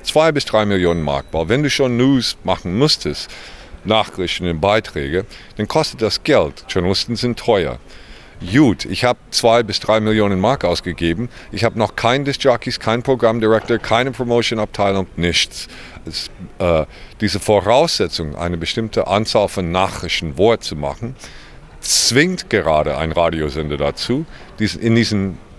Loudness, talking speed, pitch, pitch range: -17 LUFS, 140 wpm, 105 Hz, 85-120 Hz